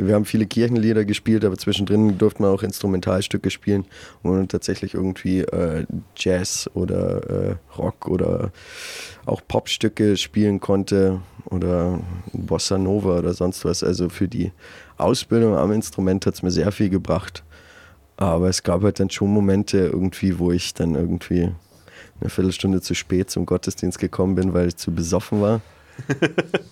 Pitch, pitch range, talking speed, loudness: 95 Hz, 90-105 Hz, 155 wpm, -21 LUFS